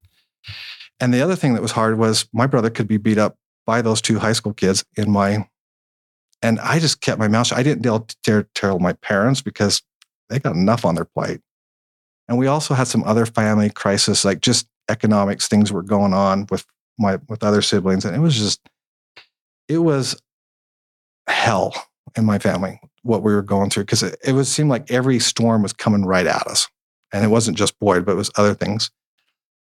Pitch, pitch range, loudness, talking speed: 110 Hz, 105-120 Hz, -18 LUFS, 205 wpm